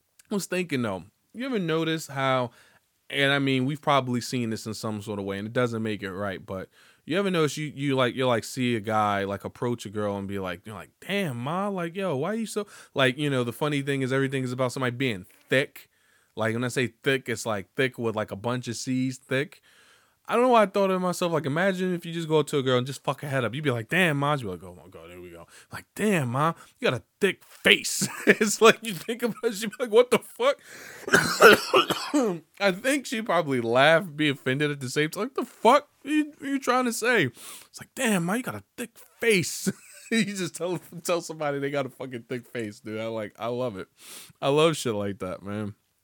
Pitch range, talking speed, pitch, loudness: 115-185 Hz, 255 wpm, 140 Hz, -26 LUFS